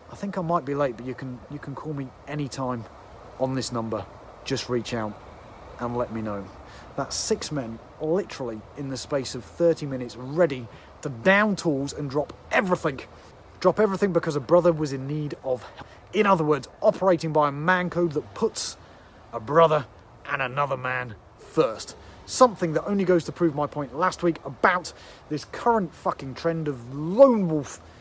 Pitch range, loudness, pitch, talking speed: 120-170 Hz, -25 LUFS, 145 Hz, 180 wpm